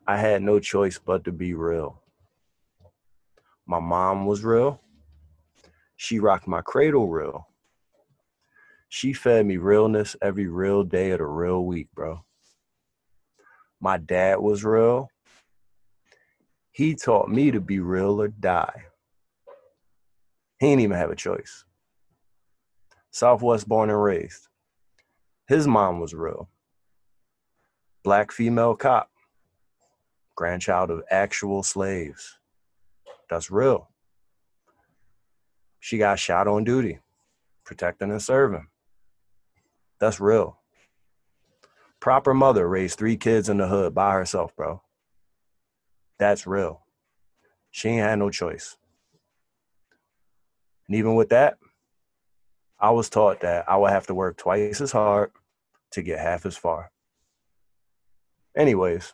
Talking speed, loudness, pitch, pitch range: 115 wpm, -23 LUFS, 100 Hz, 95-110 Hz